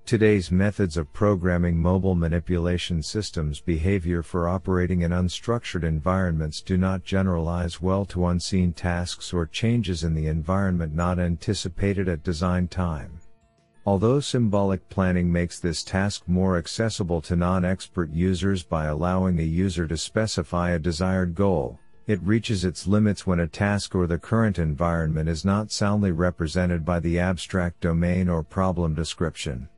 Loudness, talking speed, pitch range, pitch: -24 LUFS, 145 wpm, 85-95 Hz, 90 Hz